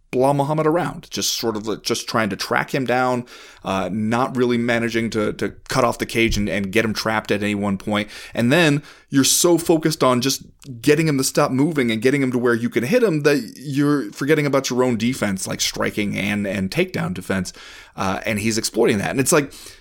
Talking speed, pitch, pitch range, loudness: 220 wpm, 125 Hz, 110-145 Hz, -20 LUFS